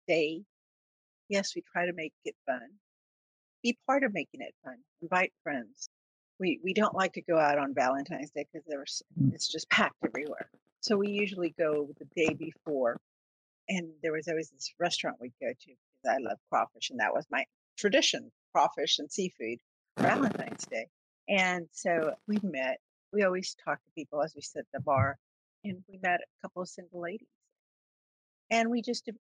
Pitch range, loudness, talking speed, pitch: 145-195 Hz, -32 LUFS, 180 wpm, 170 Hz